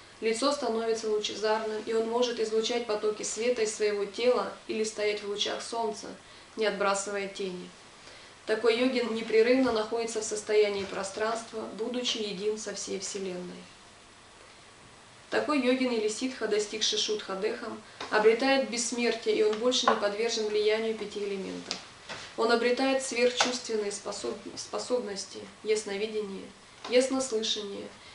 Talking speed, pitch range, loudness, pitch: 115 wpm, 205-235 Hz, -29 LUFS, 220 Hz